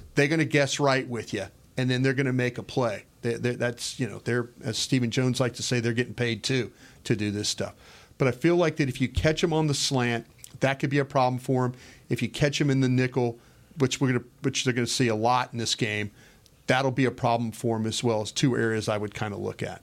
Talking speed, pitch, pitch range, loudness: 280 wpm, 125 Hz, 115-135 Hz, -26 LUFS